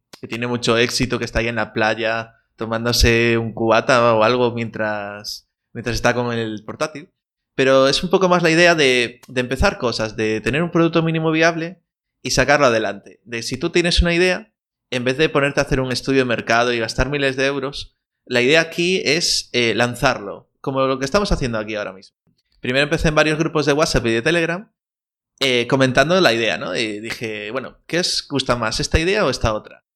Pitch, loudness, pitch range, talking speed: 125 Hz, -18 LUFS, 115-155 Hz, 205 wpm